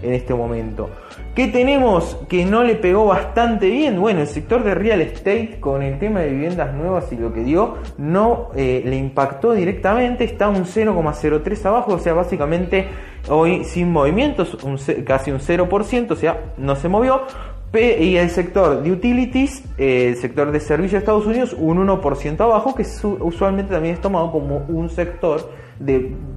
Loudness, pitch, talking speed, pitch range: -18 LUFS, 175 Hz, 170 wpm, 145-210 Hz